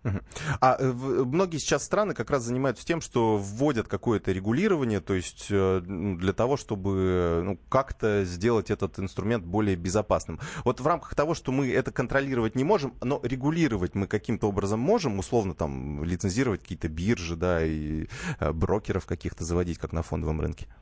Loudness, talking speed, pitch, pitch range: -28 LUFS, 155 wpm, 105 Hz, 90-130 Hz